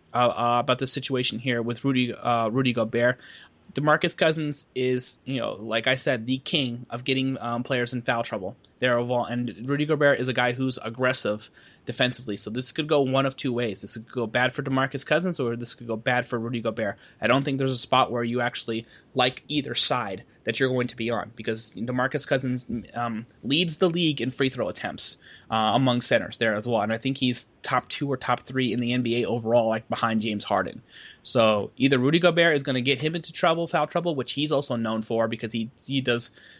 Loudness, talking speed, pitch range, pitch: -25 LUFS, 225 wpm, 115-135 Hz, 125 Hz